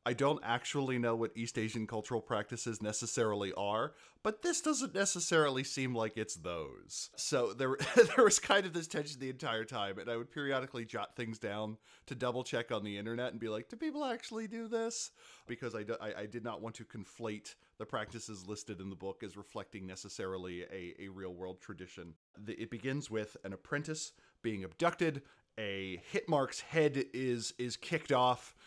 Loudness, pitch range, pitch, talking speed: -36 LUFS, 105-145 Hz, 115 Hz, 185 wpm